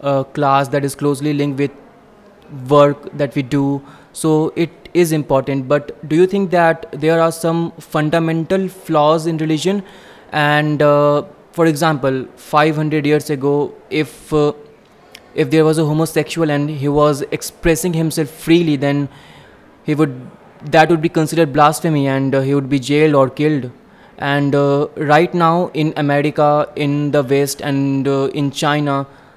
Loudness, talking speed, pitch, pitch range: -16 LUFS, 155 wpm, 150 Hz, 145-165 Hz